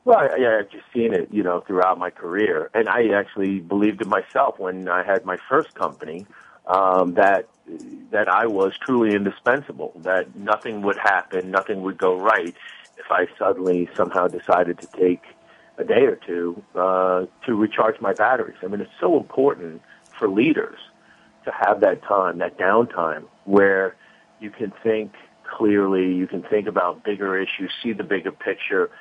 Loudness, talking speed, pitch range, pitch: -21 LUFS, 170 wpm, 90-105 Hz, 95 Hz